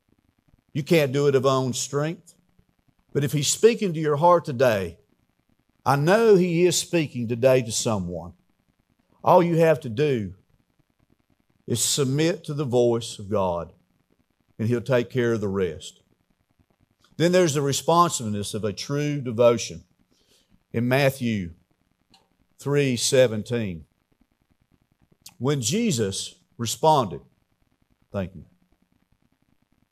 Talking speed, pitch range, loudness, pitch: 120 wpm, 115-150 Hz, -23 LUFS, 130 Hz